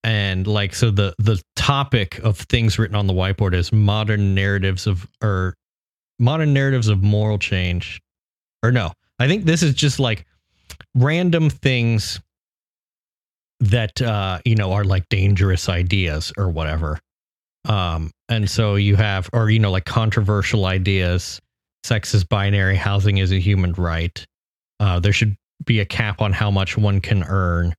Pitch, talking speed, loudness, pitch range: 100 Hz, 160 wpm, -19 LUFS, 95-110 Hz